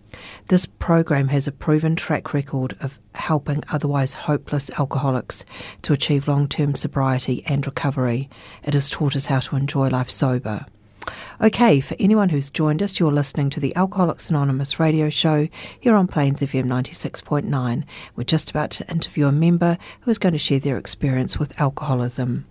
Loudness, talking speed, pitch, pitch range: -21 LUFS, 170 wpm, 145 Hz, 135-155 Hz